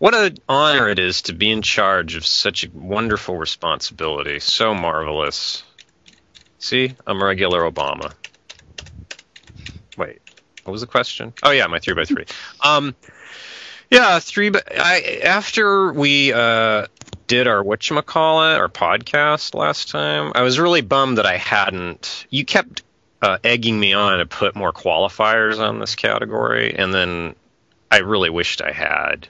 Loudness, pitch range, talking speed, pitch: -17 LUFS, 100-155 Hz, 150 wpm, 120 Hz